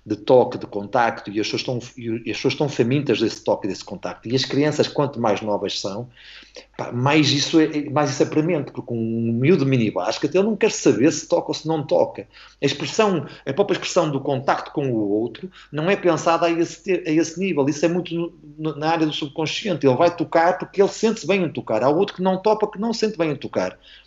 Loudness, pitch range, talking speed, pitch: -21 LUFS, 130-175 Hz, 235 wpm, 155 Hz